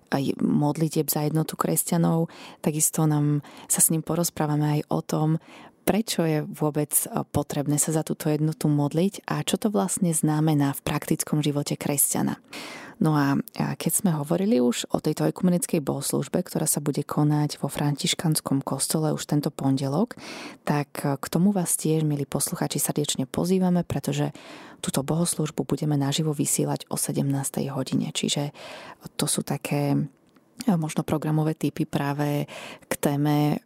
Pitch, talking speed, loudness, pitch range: 155 Hz, 145 wpm, -25 LUFS, 145-170 Hz